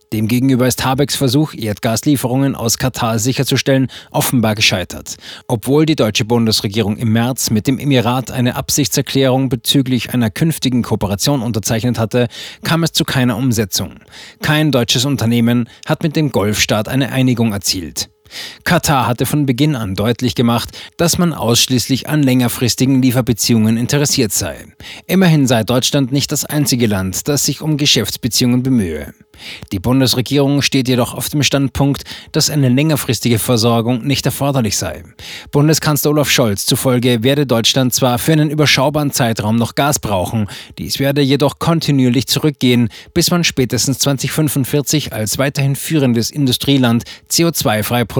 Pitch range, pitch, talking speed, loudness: 115-140 Hz, 130 Hz, 140 wpm, -14 LUFS